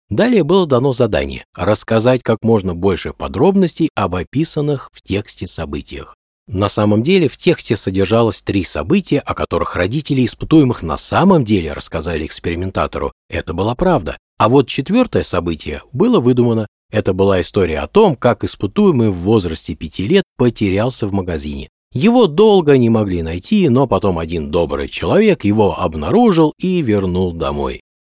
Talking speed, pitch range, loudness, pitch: 150 wpm, 95-150 Hz, -15 LUFS, 110 Hz